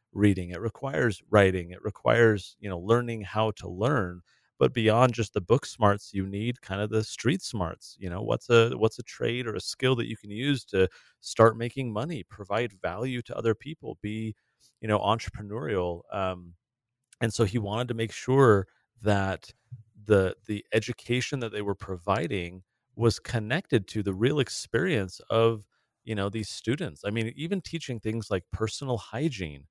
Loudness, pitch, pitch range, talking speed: -28 LUFS, 110 Hz, 100-120 Hz, 175 wpm